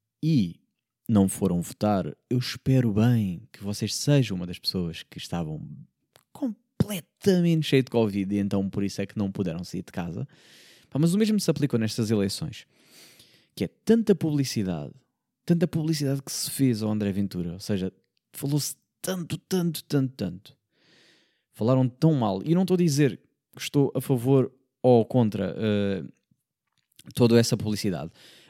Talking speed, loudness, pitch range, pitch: 155 wpm, -26 LUFS, 100-150 Hz, 120 Hz